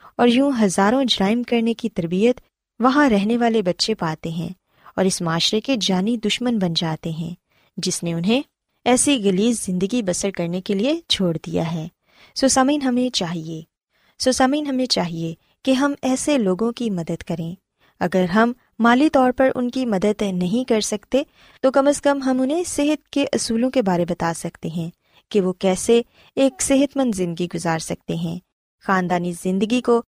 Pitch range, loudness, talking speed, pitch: 180-255 Hz, -20 LUFS, 175 wpm, 220 Hz